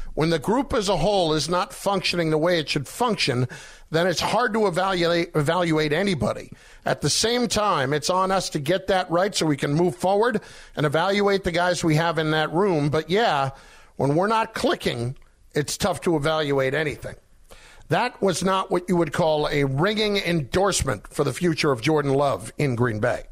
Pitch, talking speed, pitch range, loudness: 170 Hz, 195 wpm, 150-190 Hz, -22 LUFS